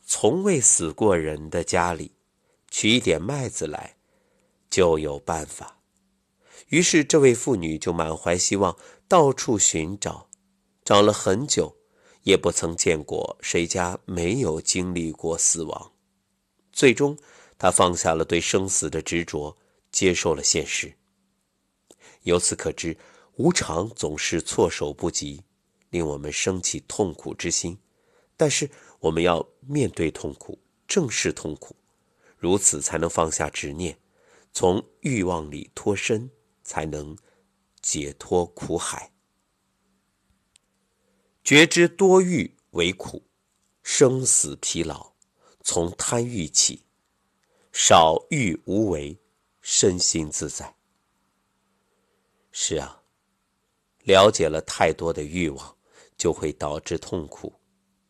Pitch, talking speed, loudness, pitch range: 85 Hz, 165 characters per minute, -22 LUFS, 80-100 Hz